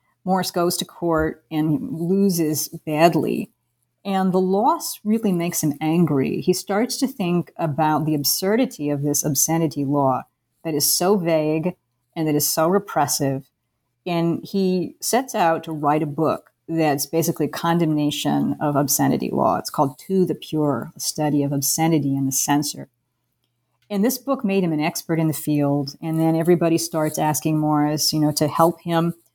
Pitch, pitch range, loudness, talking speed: 155 Hz, 145-175 Hz, -21 LUFS, 170 wpm